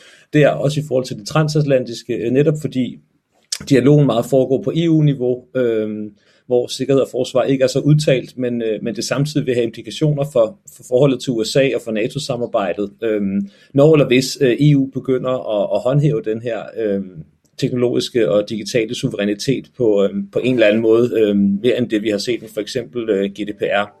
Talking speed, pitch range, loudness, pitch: 160 wpm, 105-135 Hz, -17 LUFS, 125 Hz